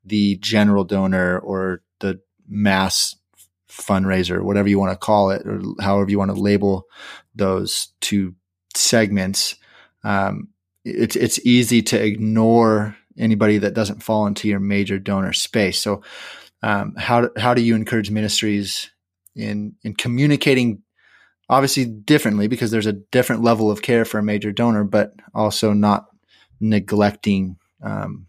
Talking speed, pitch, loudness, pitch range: 140 wpm, 105 Hz, -19 LUFS, 100-110 Hz